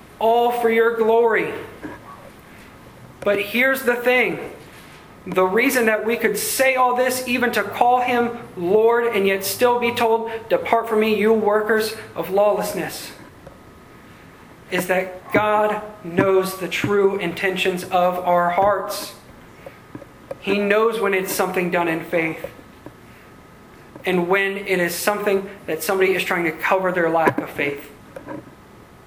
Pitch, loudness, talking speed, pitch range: 205 Hz, -19 LUFS, 135 wpm, 185-230 Hz